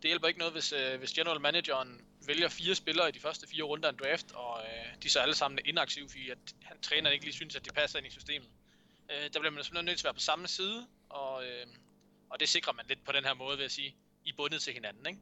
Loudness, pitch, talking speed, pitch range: -33 LUFS, 150 Hz, 280 wpm, 135-165 Hz